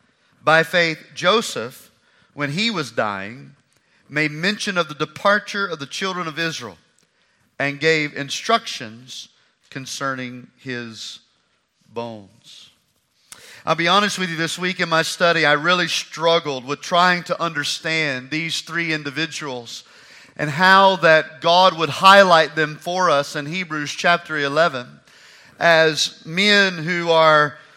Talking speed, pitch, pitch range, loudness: 130 wpm, 160 Hz, 145-175 Hz, -18 LUFS